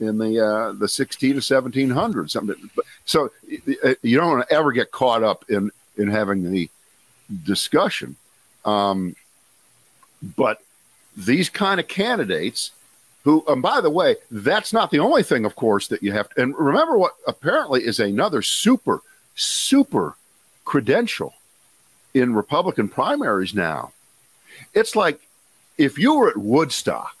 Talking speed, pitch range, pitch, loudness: 135 wpm, 105-175 Hz, 130 Hz, -20 LUFS